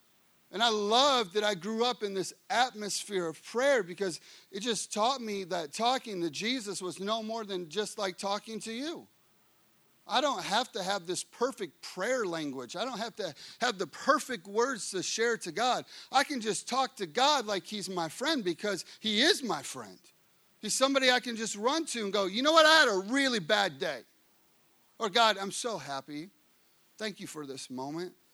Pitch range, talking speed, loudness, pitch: 190-245 Hz, 200 wpm, -30 LUFS, 215 Hz